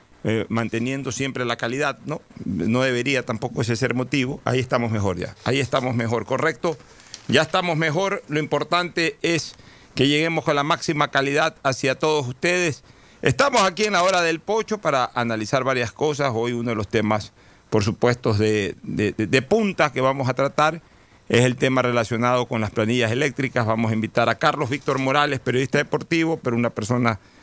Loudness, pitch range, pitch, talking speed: -22 LUFS, 120-150 Hz, 130 Hz, 180 wpm